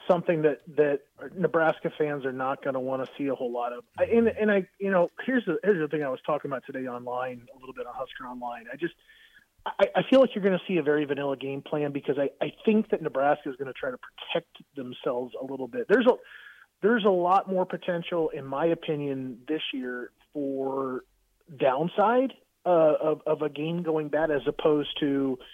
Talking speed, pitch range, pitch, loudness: 220 wpm, 135-185 Hz, 155 Hz, -27 LUFS